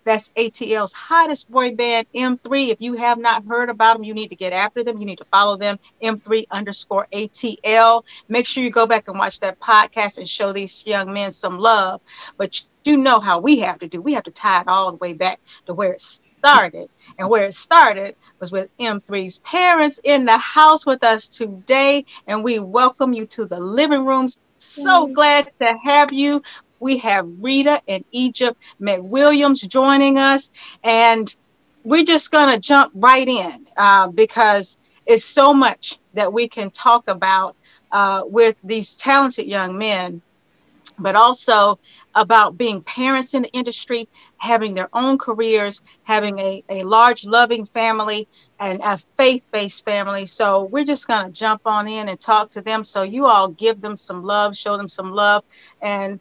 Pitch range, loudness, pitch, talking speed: 200-260 Hz, -16 LUFS, 225 Hz, 180 wpm